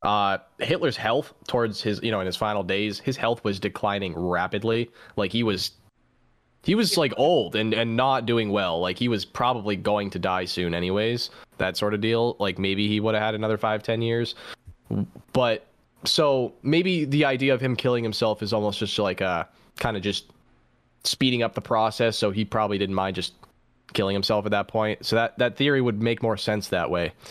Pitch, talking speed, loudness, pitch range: 110 Hz, 205 wpm, -25 LUFS, 100-115 Hz